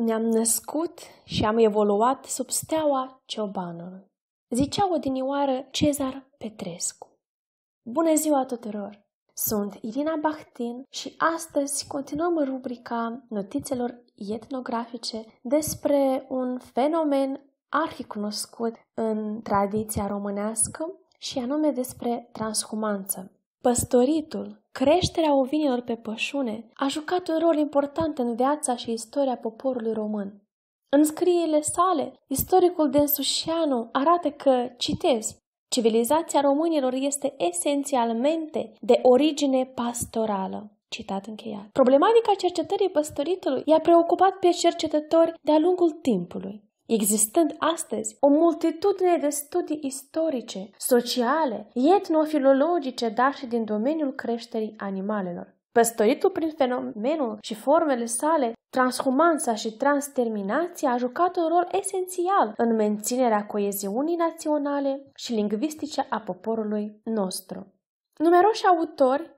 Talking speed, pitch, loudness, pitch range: 100 wpm, 265 Hz, -25 LUFS, 225-310 Hz